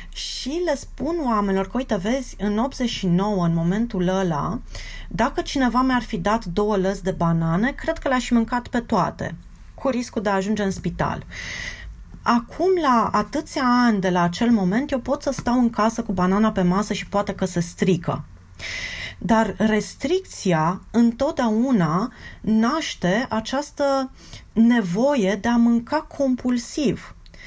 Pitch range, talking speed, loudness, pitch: 195-255 Hz, 145 wpm, -22 LUFS, 225 Hz